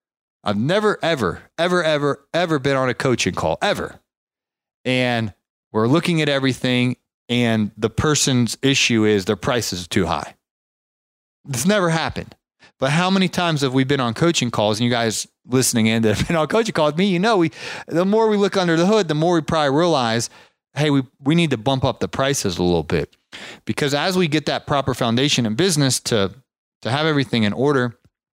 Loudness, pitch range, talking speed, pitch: -19 LUFS, 115-160 Hz, 200 wpm, 135 Hz